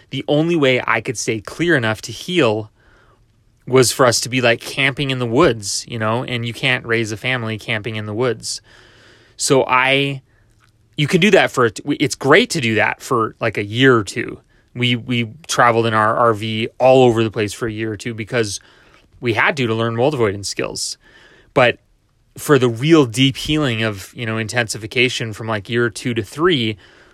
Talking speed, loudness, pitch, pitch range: 200 wpm, -17 LUFS, 120 Hz, 110-130 Hz